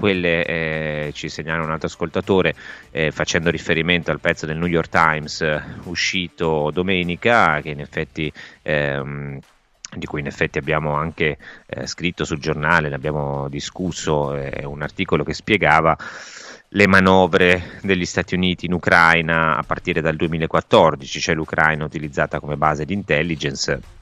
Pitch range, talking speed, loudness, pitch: 75-90 Hz, 150 wpm, -19 LUFS, 80 Hz